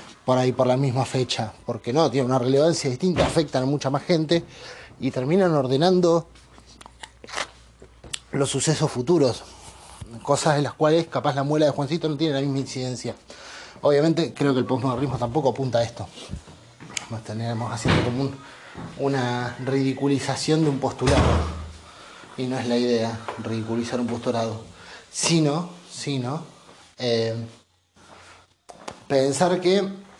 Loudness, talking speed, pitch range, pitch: -23 LUFS, 135 wpm, 120-150 Hz, 135 Hz